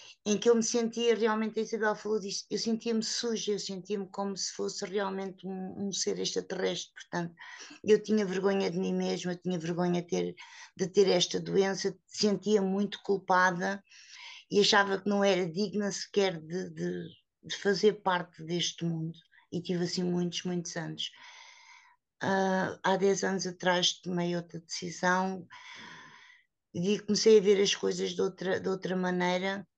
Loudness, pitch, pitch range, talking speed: -30 LUFS, 195 Hz, 180-210 Hz, 165 wpm